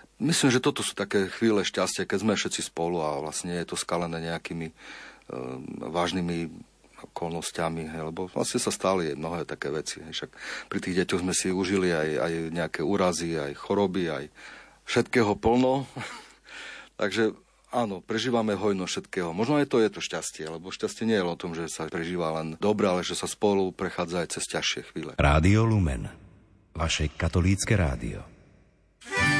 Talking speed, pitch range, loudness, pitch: 165 wpm, 80-105 Hz, -28 LUFS, 90 Hz